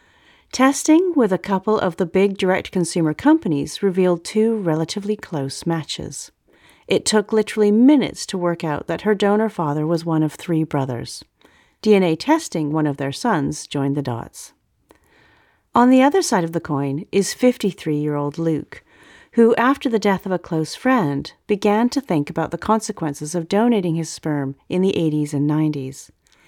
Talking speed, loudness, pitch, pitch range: 170 wpm, -19 LUFS, 180 Hz, 155-215 Hz